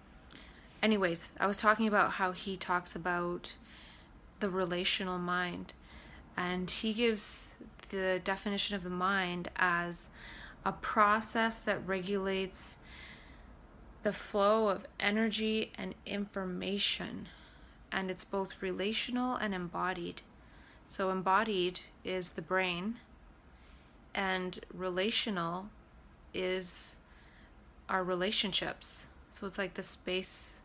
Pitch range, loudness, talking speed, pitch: 180-205 Hz, -34 LUFS, 100 wpm, 190 Hz